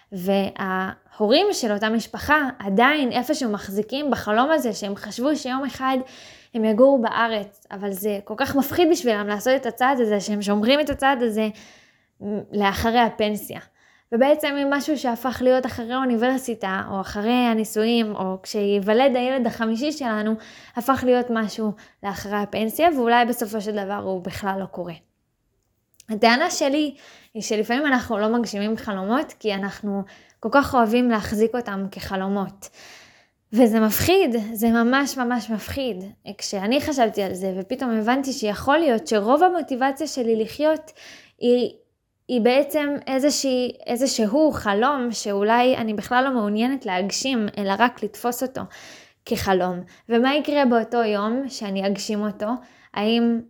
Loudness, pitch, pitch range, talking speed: -22 LUFS, 230 Hz, 210-260 Hz, 135 wpm